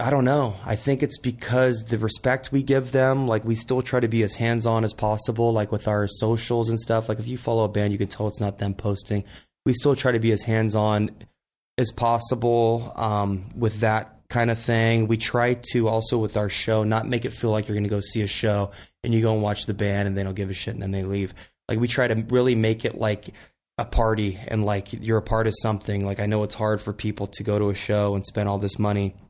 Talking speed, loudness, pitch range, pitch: 260 wpm, -24 LUFS, 105-115 Hz, 110 Hz